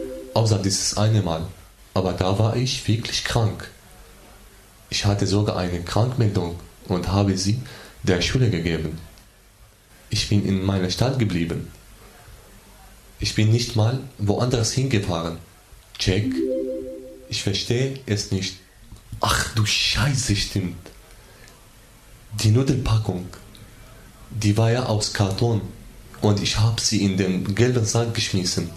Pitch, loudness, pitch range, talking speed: 105 Hz, -22 LUFS, 95-115 Hz, 120 wpm